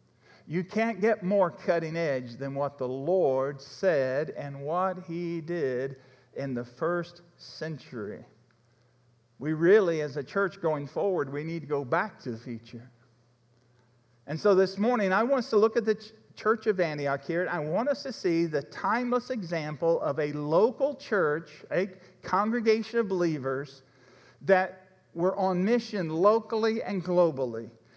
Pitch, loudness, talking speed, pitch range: 165 Hz, -28 LUFS, 155 wpm, 135-195 Hz